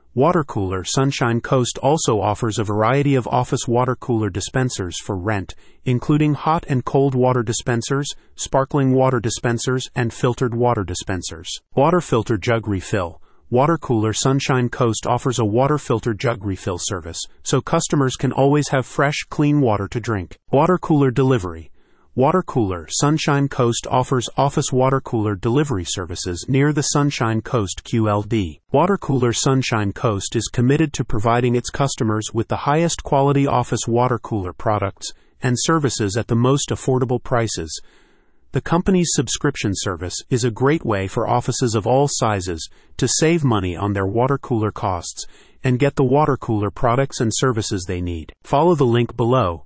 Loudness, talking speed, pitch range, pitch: -19 LUFS, 160 wpm, 110-135 Hz, 125 Hz